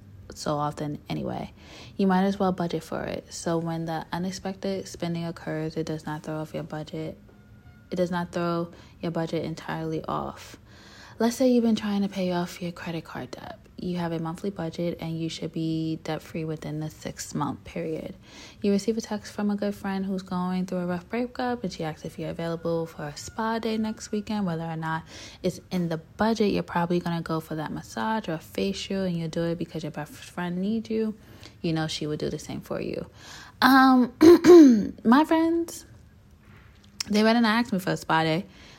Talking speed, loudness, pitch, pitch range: 205 wpm, -26 LUFS, 170 Hz, 160-205 Hz